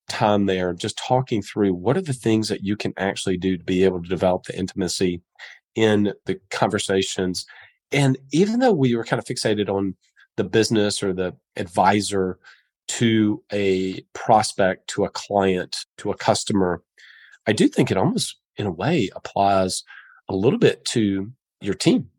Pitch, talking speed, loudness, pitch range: 100 Hz, 170 wpm, -22 LUFS, 95-110 Hz